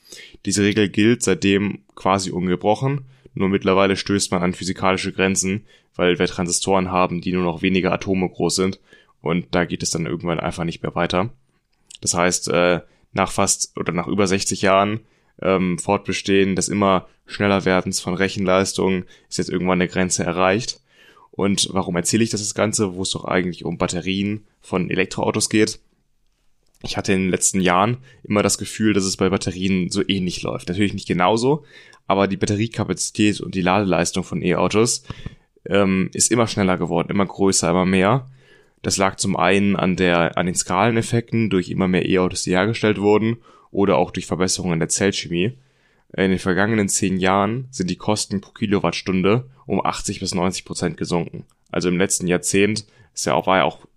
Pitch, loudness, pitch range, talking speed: 95 Hz, -20 LUFS, 90-105 Hz, 175 wpm